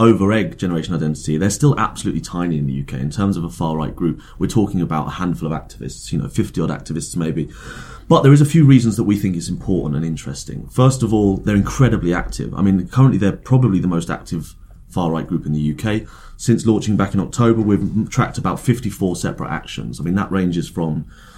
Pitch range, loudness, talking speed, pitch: 85-110 Hz, -18 LUFS, 225 wpm, 95 Hz